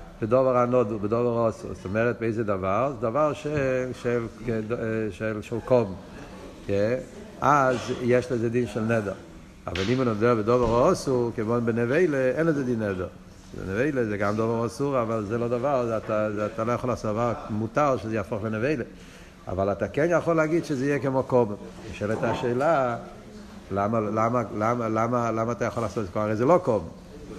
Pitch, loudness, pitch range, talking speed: 115 Hz, -25 LUFS, 110-125 Hz, 170 wpm